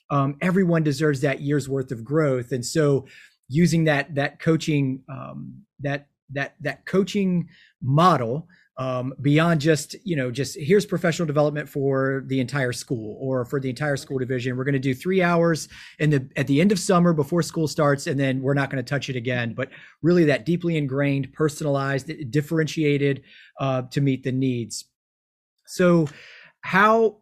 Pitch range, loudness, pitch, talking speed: 135-165 Hz, -23 LUFS, 145 Hz, 170 wpm